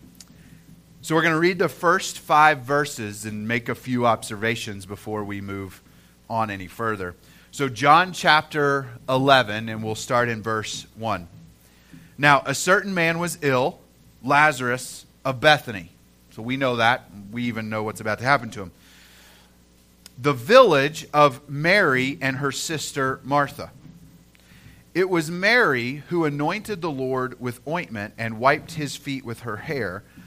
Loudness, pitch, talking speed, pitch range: -22 LUFS, 125 Hz, 150 wpm, 105-150 Hz